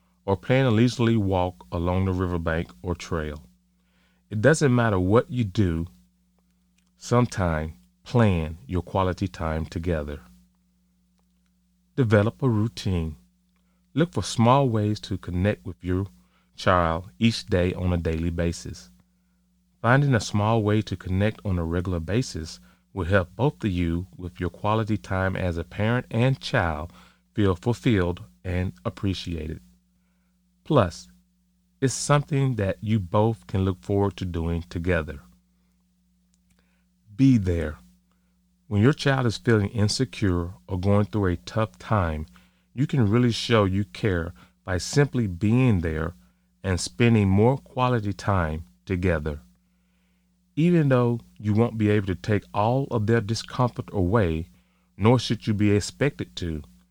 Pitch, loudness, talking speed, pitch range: 90 Hz, -24 LUFS, 135 wpm, 80-110 Hz